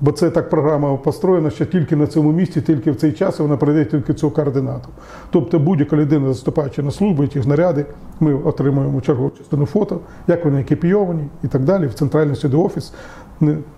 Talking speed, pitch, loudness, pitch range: 185 wpm, 155 Hz, -17 LUFS, 145-165 Hz